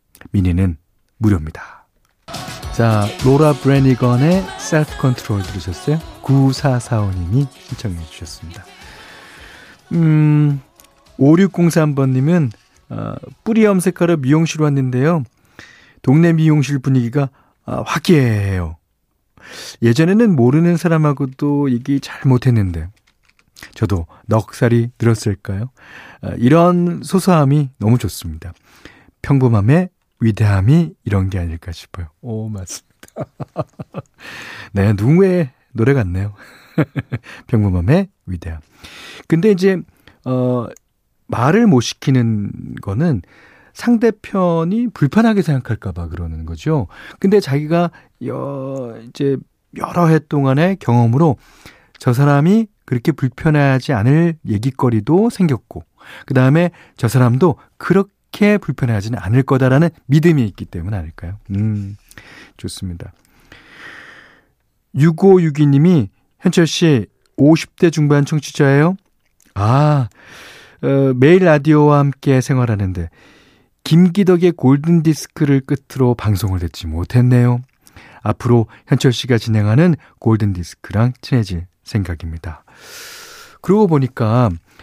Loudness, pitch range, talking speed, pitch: -15 LUFS, 105-160 Hz, 240 characters per minute, 130 Hz